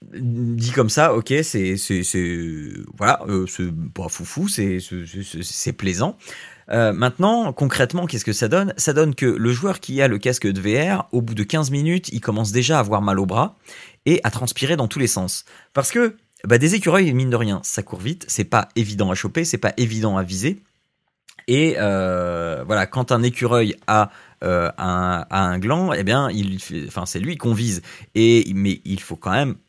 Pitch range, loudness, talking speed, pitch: 100-140 Hz, -20 LUFS, 210 wpm, 115 Hz